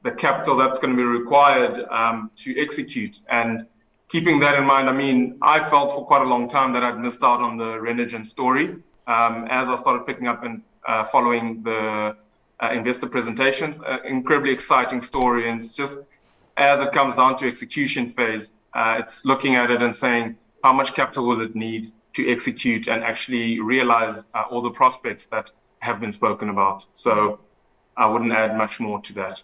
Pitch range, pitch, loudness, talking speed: 115-135 Hz, 120 Hz, -21 LUFS, 190 wpm